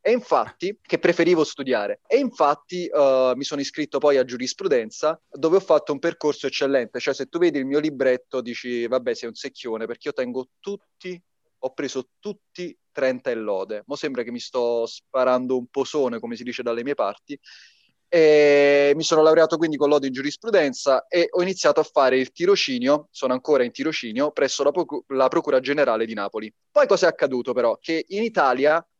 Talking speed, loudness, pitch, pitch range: 190 wpm, -22 LUFS, 145 Hz, 130-170 Hz